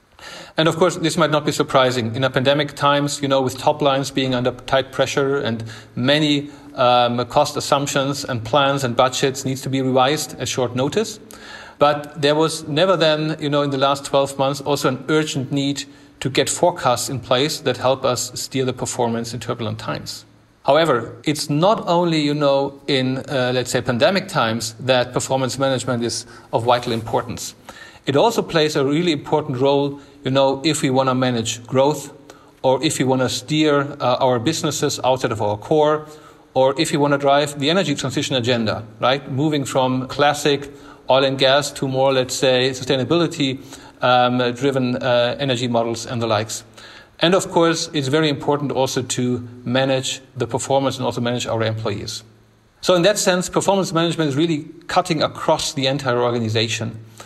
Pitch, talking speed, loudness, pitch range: 135 Hz, 180 wpm, -19 LUFS, 125-145 Hz